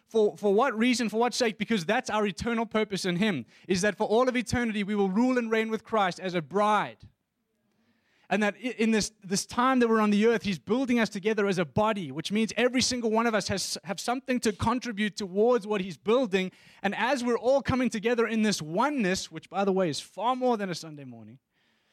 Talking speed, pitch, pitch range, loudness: 230 wpm, 215 Hz, 195-235 Hz, -27 LUFS